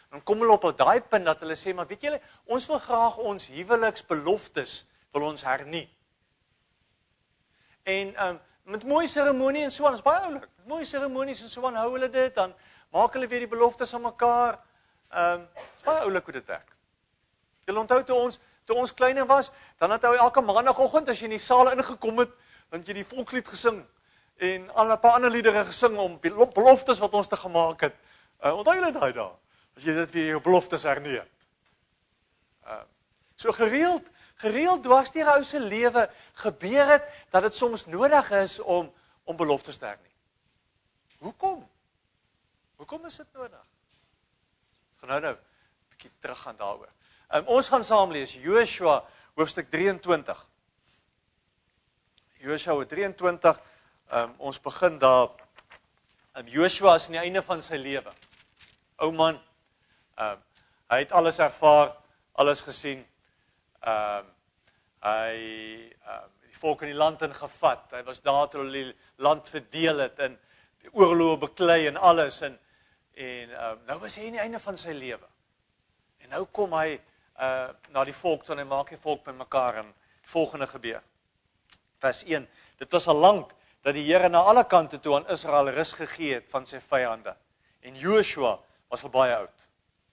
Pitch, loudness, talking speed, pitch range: 180 Hz, -25 LUFS, 170 wpm, 145-240 Hz